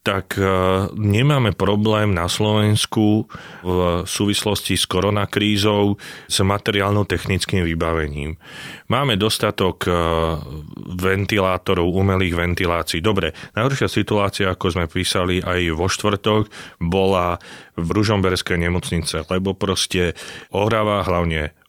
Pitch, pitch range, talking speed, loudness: 95 Hz, 90-105 Hz, 95 wpm, -19 LUFS